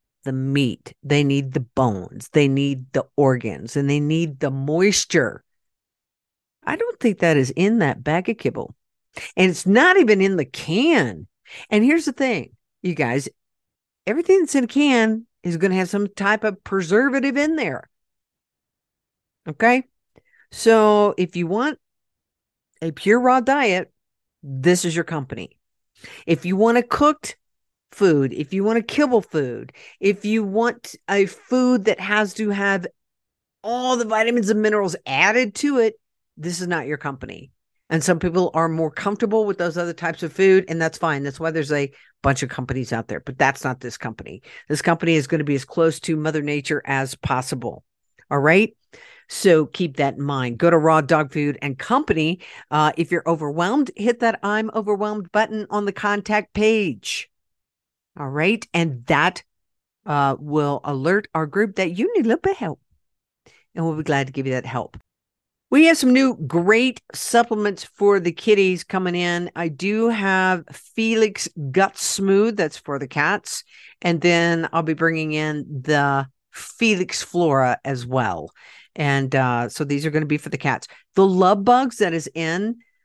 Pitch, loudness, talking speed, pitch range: 175 Hz, -20 LUFS, 175 wpm, 145-215 Hz